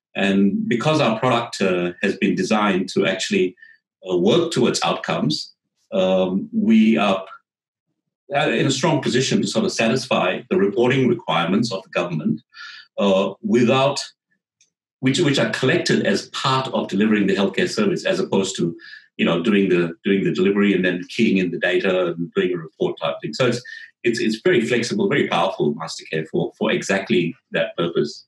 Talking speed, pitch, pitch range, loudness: 170 wpm, 100 Hz, 95-130 Hz, -20 LUFS